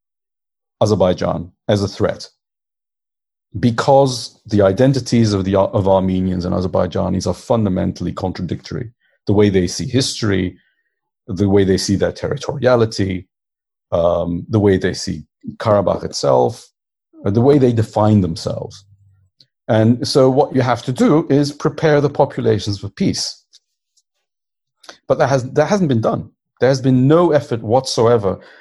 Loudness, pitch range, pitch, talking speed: -16 LUFS, 95-130 Hz, 110 Hz, 135 wpm